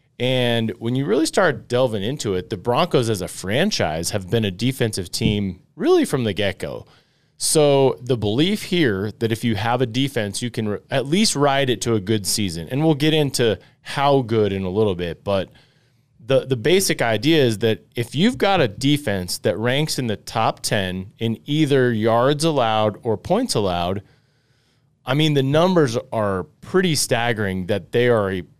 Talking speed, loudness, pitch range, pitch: 185 wpm, -20 LUFS, 105-140 Hz, 120 Hz